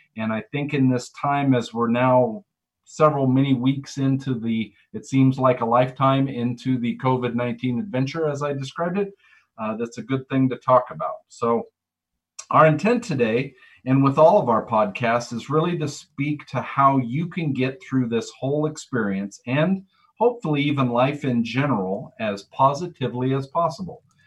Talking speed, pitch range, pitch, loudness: 170 wpm, 120-150 Hz, 135 Hz, -22 LUFS